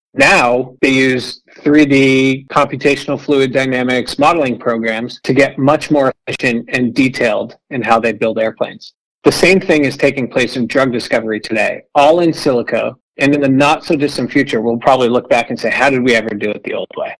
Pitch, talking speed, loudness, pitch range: 130 Hz, 195 wpm, -13 LUFS, 120-140 Hz